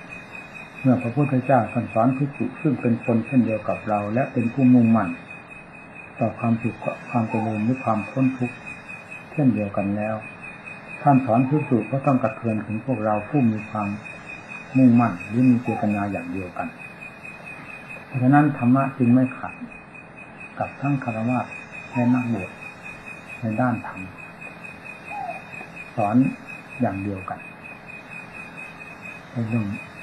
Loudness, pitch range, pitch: -22 LUFS, 110-130 Hz, 120 Hz